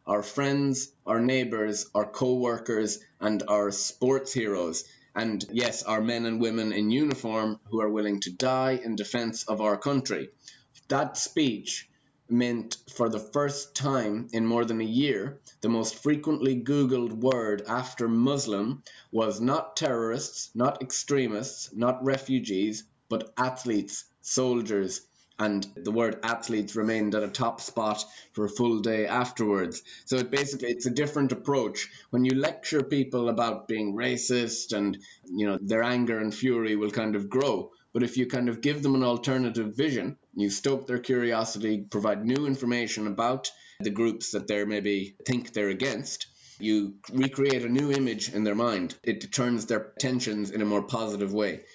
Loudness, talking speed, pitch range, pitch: -28 LUFS, 160 wpm, 105-130 Hz, 115 Hz